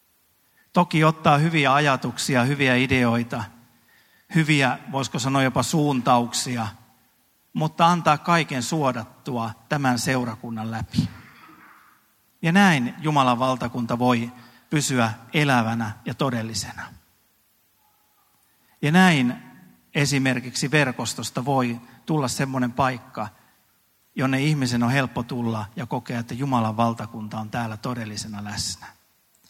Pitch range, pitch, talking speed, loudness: 115-145 Hz, 125 Hz, 100 wpm, -23 LUFS